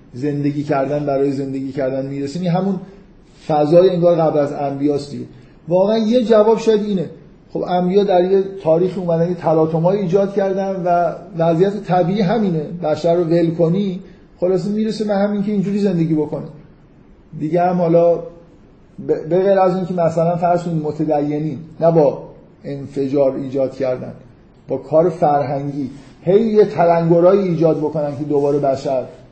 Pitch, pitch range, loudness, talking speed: 170 Hz, 145-185 Hz, -17 LUFS, 145 wpm